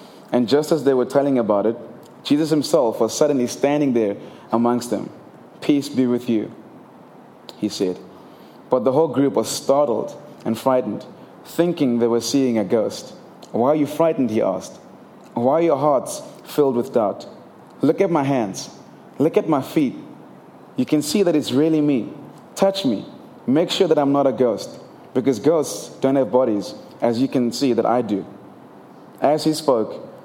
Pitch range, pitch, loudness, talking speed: 120-150 Hz, 135 Hz, -20 LUFS, 175 wpm